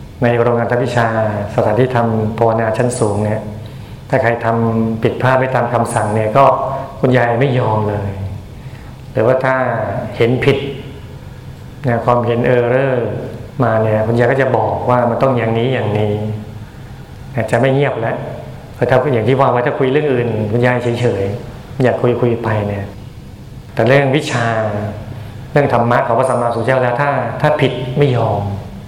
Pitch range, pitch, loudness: 110-130 Hz, 120 Hz, -15 LUFS